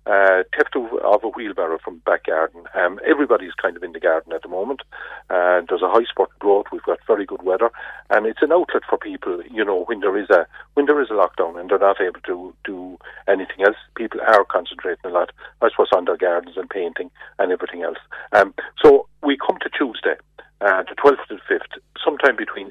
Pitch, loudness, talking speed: 170 Hz, -20 LUFS, 220 wpm